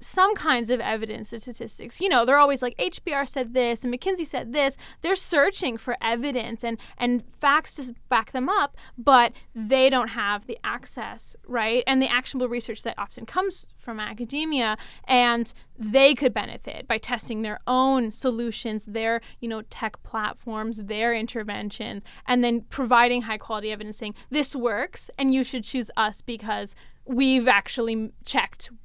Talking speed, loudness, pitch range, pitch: 165 wpm, -24 LUFS, 225-265 Hz, 245 Hz